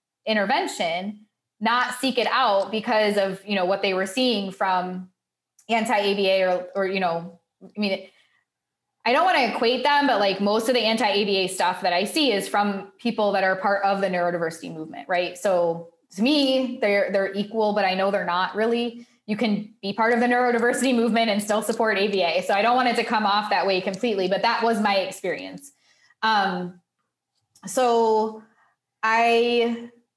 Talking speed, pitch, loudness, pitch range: 180 wpm, 210 Hz, -22 LUFS, 195-235 Hz